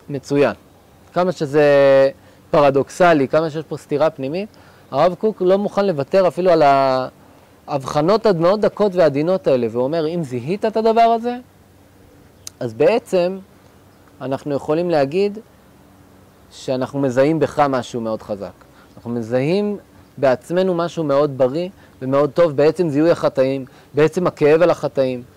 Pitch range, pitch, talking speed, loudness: 125-175 Hz, 140 Hz, 130 wpm, -17 LUFS